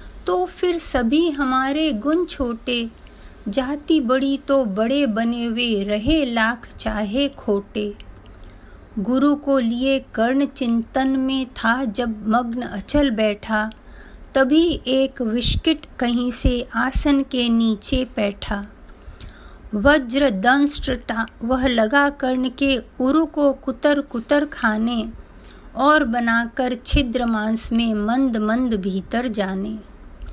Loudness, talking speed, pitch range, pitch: -20 LUFS, 110 wpm, 225-275 Hz, 245 Hz